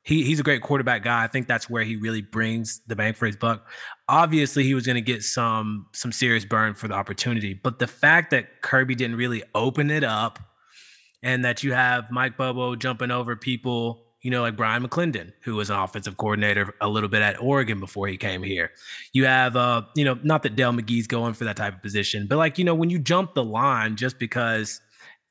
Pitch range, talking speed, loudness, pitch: 110-130 Hz, 225 wpm, -23 LUFS, 120 Hz